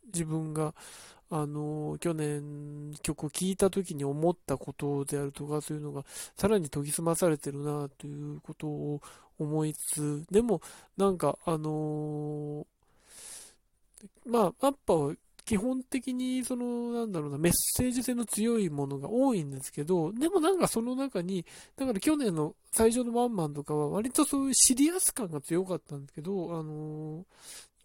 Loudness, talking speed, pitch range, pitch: -30 LUFS, 320 characters per minute, 150-225 Hz, 165 Hz